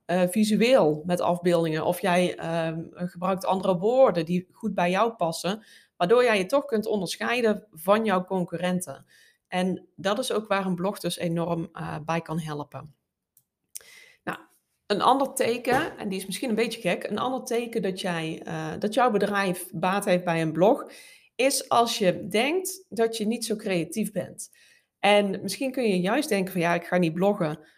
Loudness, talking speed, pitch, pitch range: -25 LUFS, 180 wpm, 190 Hz, 175-220 Hz